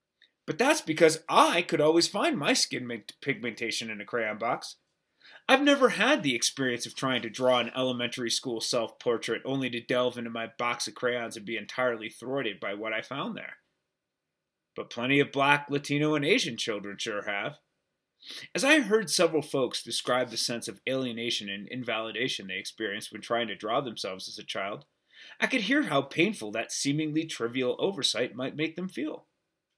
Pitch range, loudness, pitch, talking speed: 115-155 Hz, -28 LUFS, 125 Hz, 180 wpm